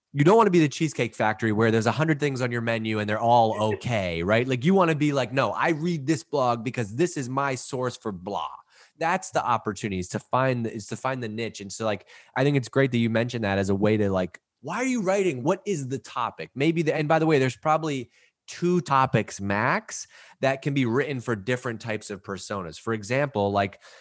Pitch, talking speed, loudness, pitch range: 125 Hz, 240 wpm, -25 LUFS, 110-145 Hz